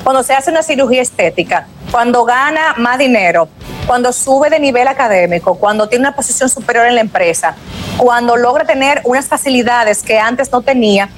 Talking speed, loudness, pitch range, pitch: 170 wpm, -11 LUFS, 225-270 Hz, 245 Hz